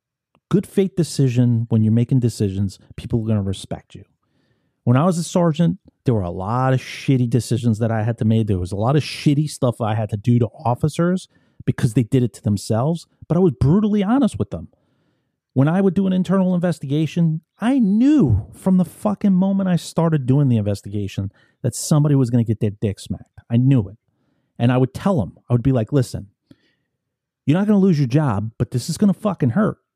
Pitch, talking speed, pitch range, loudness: 130 Hz, 220 wpm, 115-165 Hz, -19 LUFS